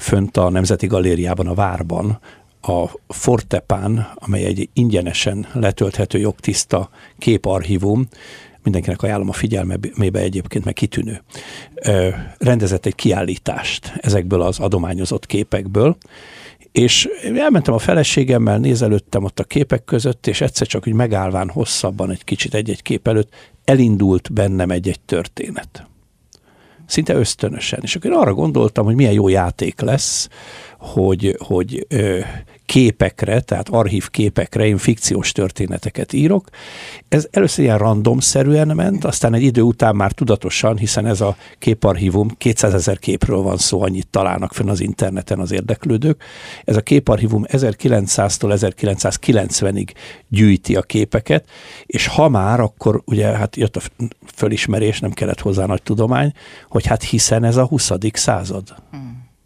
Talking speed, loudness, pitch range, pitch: 130 wpm, -17 LUFS, 95-120 Hz, 105 Hz